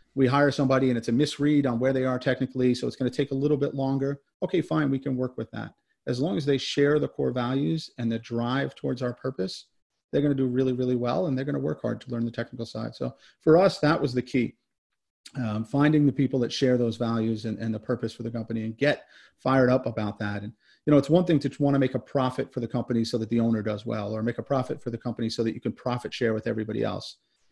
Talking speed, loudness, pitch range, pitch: 275 wpm, -26 LUFS, 115-140 Hz, 125 Hz